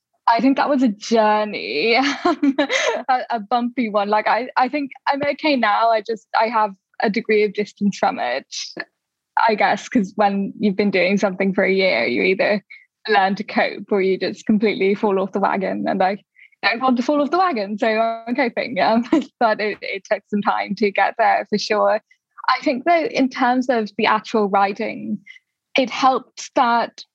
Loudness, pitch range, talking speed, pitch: -19 LUFS, 205-265 Hz, 190 wpm, 225 Hz